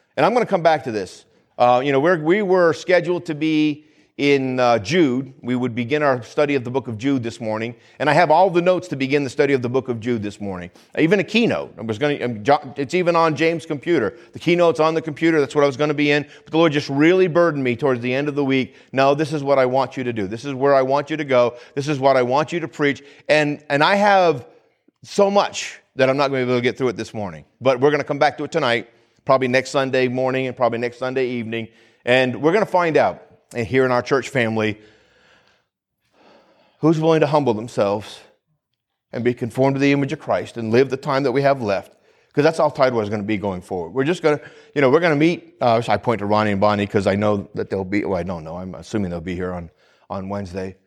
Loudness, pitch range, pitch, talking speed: -19 LUFS, 115-150 Hz, 135 Hz, 265 wpm